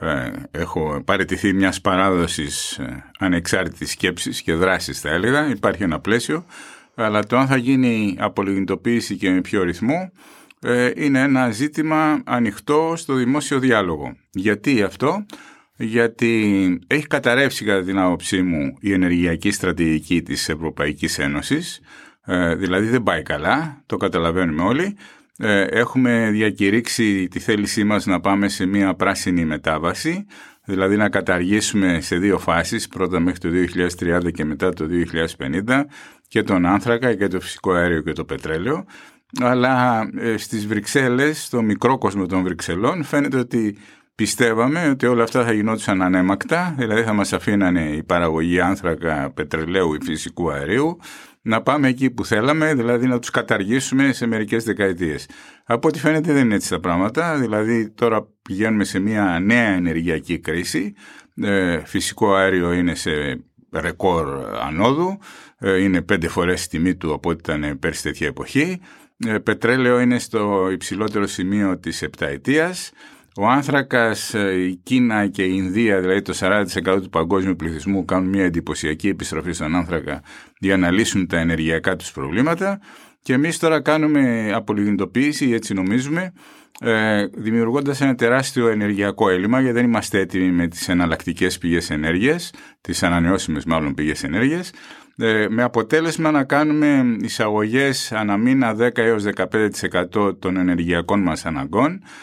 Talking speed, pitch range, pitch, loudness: 140 wpm, 90-120 Hz, 100 Hz, -19 LUFS